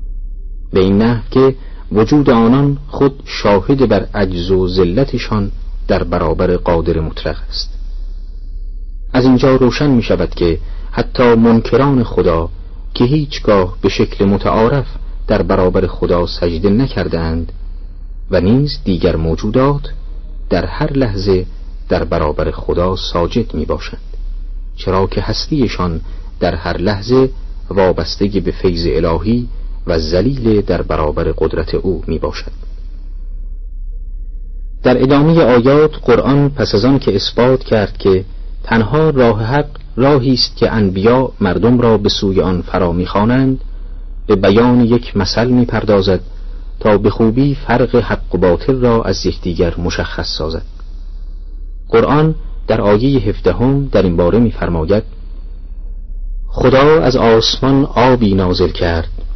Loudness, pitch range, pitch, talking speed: -13 LUFS, 85-120 Hz, 95 Hz, 125 wpm